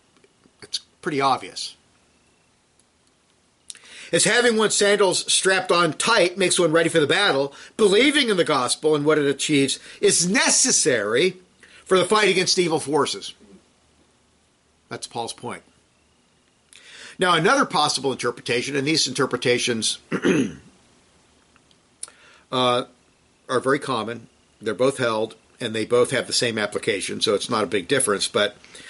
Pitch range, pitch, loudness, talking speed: 125-185 Hz, 155 Hz, -20 LUFS, 130 wpm